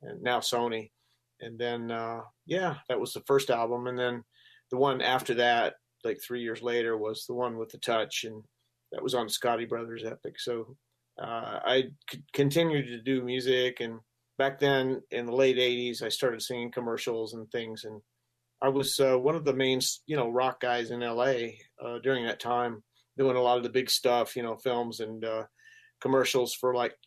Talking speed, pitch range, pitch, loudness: 195 wpm, 115-130 Hz, 120 Hz, -30 LUFS